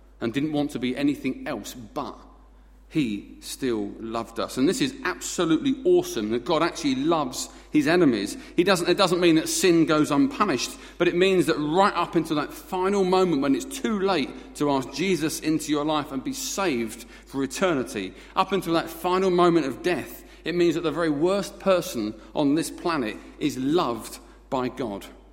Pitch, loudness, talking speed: 175 Hz, -24 LUFS, 185 wpm